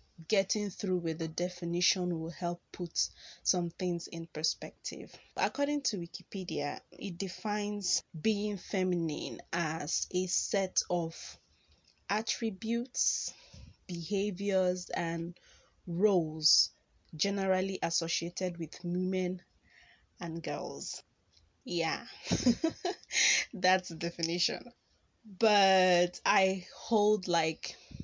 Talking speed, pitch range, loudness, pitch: 90 wpm, 170-200 Hz, -32 LUFS, 180 Hz